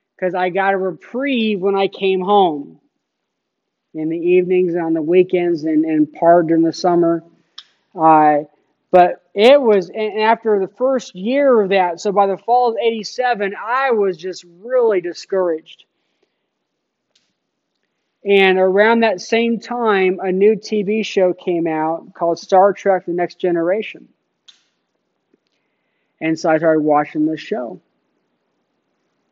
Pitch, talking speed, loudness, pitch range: 185 Hz, 140 wpm, -16 LUFS, 170-215 Hz